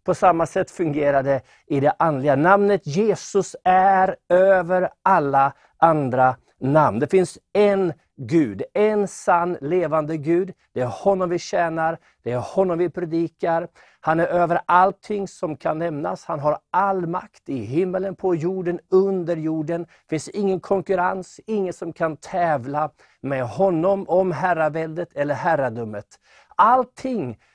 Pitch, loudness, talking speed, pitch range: 175 Hz, -21 LUFS, 140 wpm, 155-190 Hz